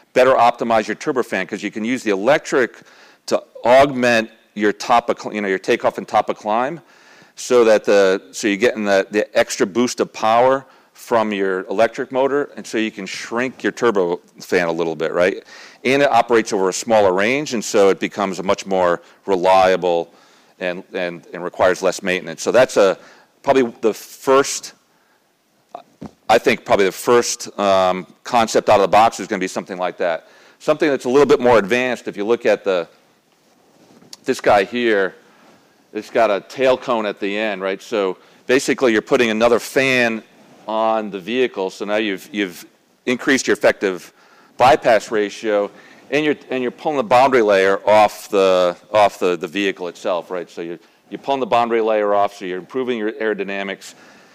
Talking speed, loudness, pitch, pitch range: 185 wpm, -18 LUFS, 105 Hz, 95-120 Hz